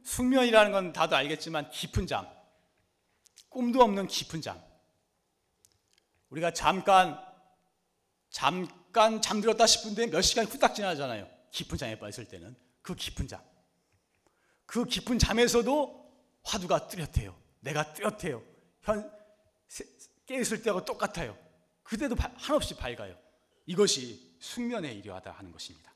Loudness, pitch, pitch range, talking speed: -29 LUFS, 190 Hz, 150-230 Hz, 265 characters per minute